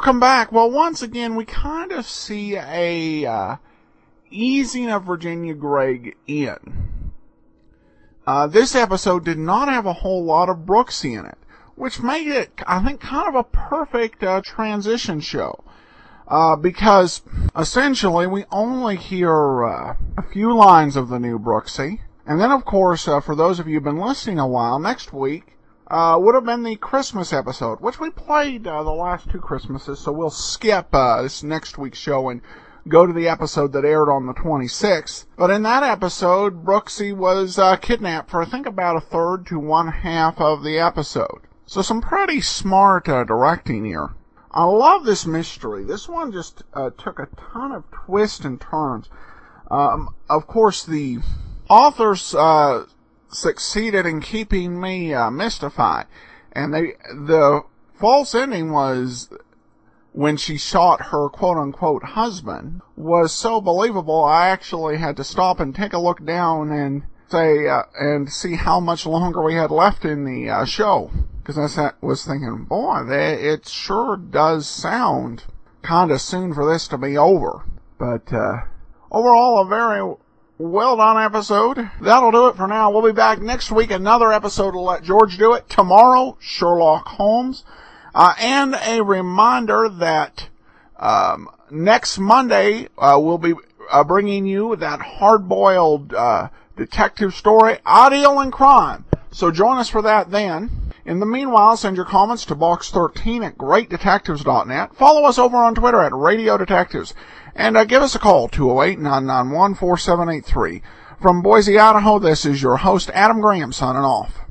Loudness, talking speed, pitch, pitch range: -17 LUFS, 165 wpm, 180 Hz, 150-220 Hz